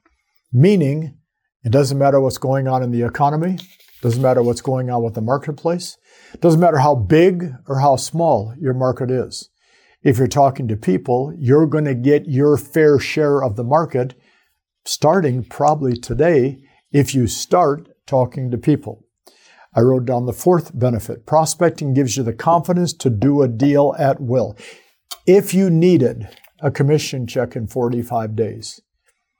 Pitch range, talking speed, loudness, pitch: 125-155 Hz, 160 wpm, -17 LUFS, 135 Hz